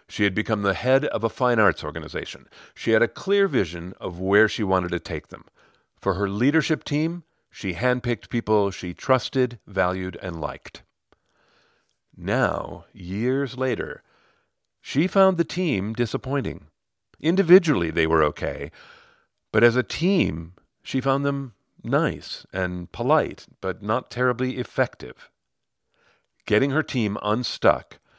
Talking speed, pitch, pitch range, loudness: 135 wpm, 120 Hz, 95-135 Hz, -24 LUFS